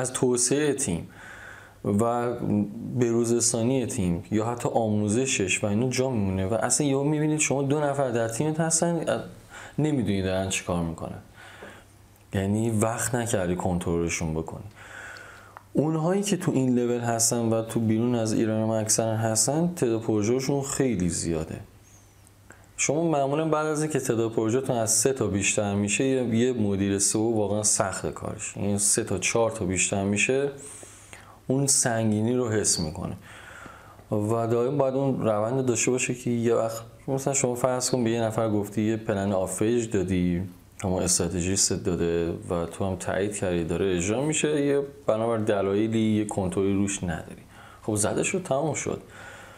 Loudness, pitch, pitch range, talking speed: -25 LUFS, 110 Hz, 100-130 Hz, 150 wpm